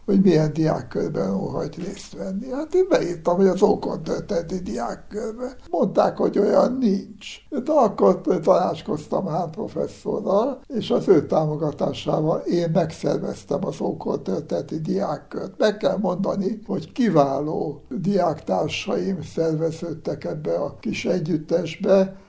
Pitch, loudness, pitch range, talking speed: 190 Hz, -23 LUFS, 165-210 Hz, 115 wpm